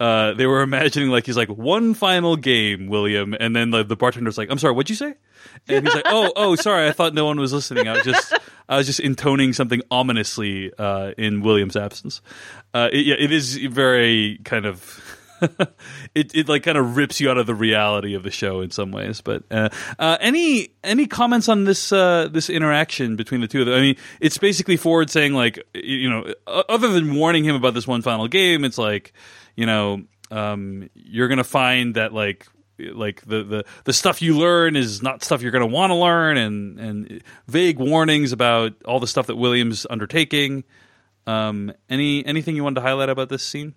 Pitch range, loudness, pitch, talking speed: 110-155 Hz, -19 LUFS, 130 Hz, 210 wpm